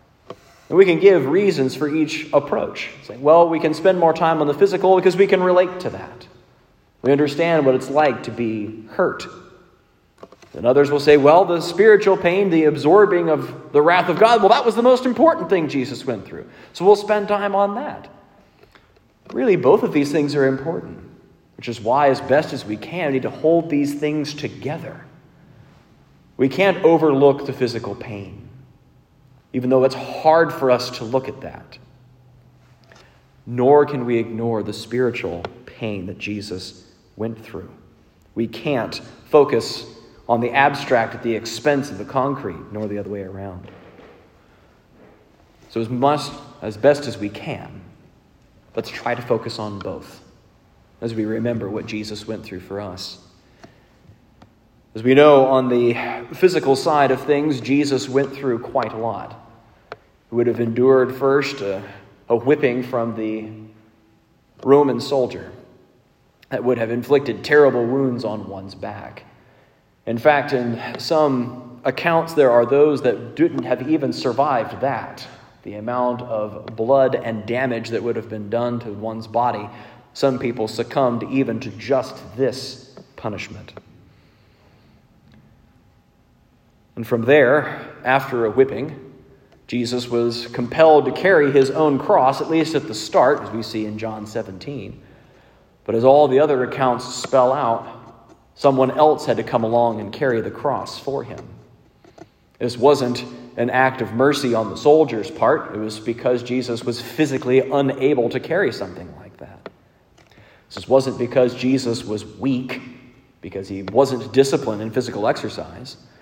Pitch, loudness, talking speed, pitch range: 130 Hz, -19 LUFS, 155 wpm, 115-145 Hz